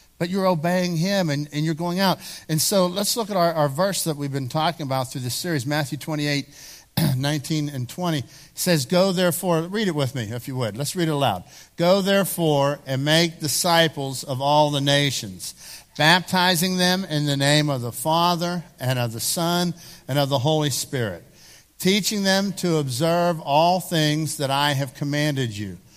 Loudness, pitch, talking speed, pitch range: -22 LUFS, 155 Hz, 185 wpm, 140-175 Hz